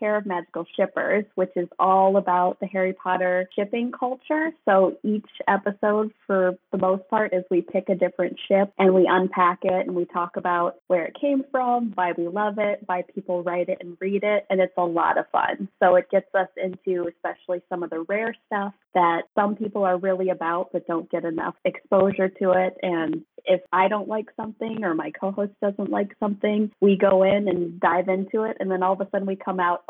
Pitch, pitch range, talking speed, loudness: 190 Hz, 180-205 Hz, 215 wpm, -23 LUFS